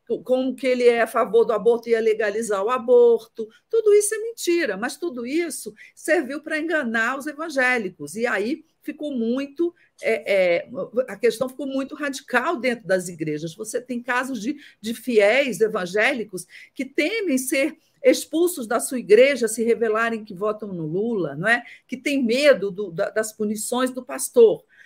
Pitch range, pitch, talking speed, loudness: 220-285 Hz, 245 Hz, 155 wpm, -22 LUFS